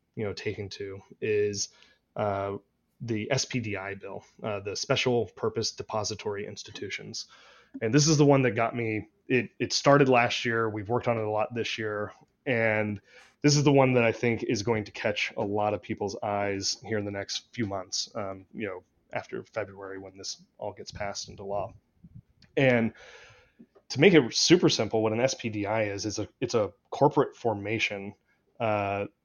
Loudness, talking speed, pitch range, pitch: -28 LUFS, 180 wpm, 100-120 Hz, 110 Hz